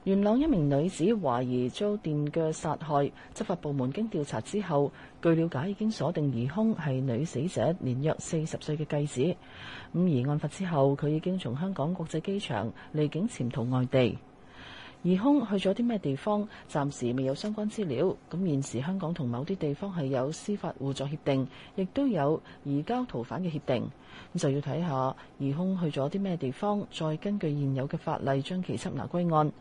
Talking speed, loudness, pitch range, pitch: 275 characters per minute, -30 LUFS, 135-185 Hz, 155 Hz